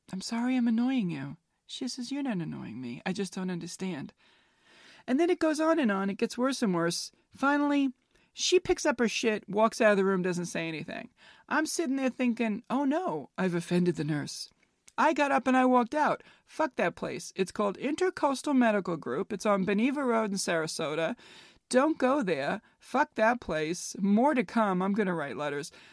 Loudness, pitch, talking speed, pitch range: -29 LUFS, 225 Hz, 200 wpm, 185-270 Hz